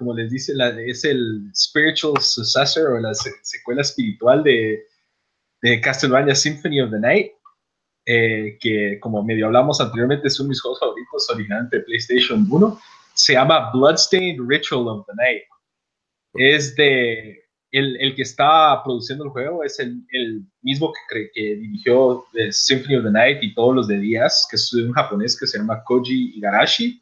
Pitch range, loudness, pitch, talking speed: 115-145 Hz, -18 LUFS, 125 Hz, 170 wpm